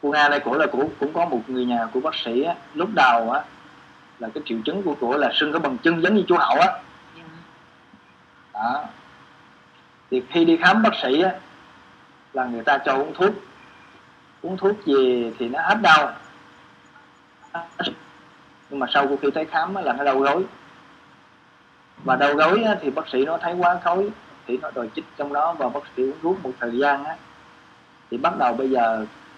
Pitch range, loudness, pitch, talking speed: 120-165 Hz, -21 LUFS, 135 Hz, 195 wpm